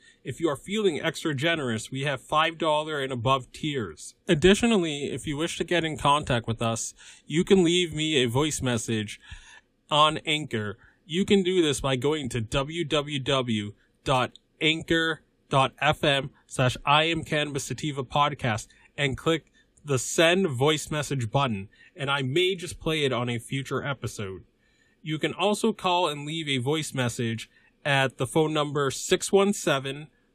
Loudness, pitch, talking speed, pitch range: -26 LUFS, 145 Hz, 140 wpm, 130-165 Hz